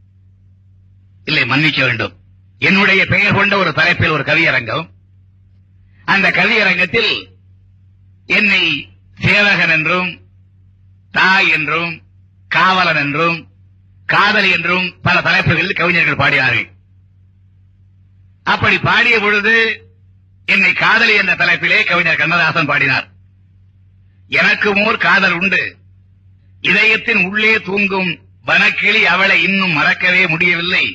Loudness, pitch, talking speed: -12 LUFS, 140 Hz, 90 wpm